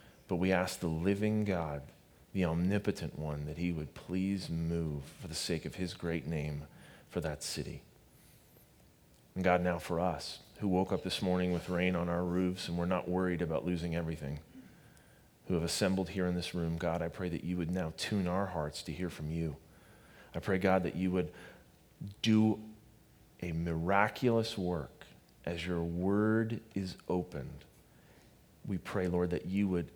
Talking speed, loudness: 175 wpm, -35 LUFS